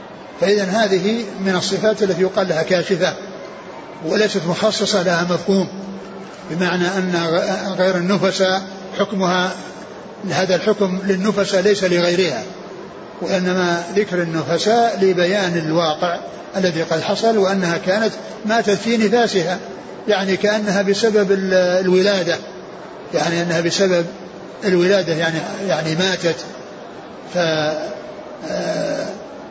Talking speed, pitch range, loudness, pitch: 95 wpm, 175-200 Hz, -18 LUFS, 190 Hz